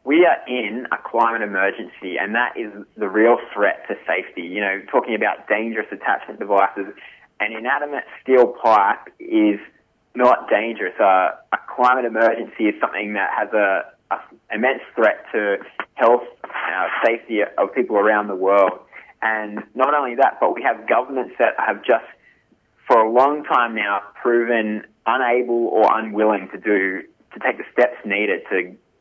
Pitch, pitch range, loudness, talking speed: 110 Hz, 105-120 Hz, -19 LUFS, 160 wpm